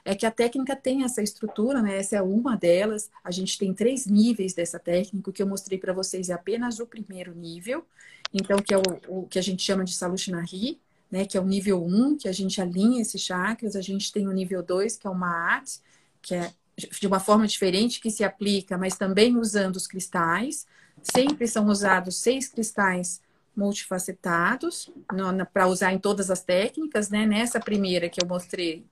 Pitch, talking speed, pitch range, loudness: 195 Hz, 195 wpm, 185-220 Hz, -25 LUFS